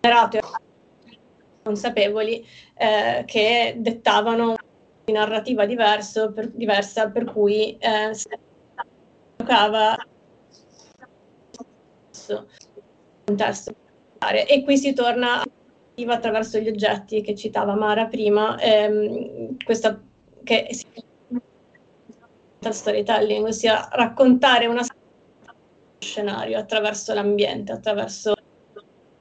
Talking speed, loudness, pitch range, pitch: 75 wpm, -21 LUFS, 215-235 Hz, 220 Hz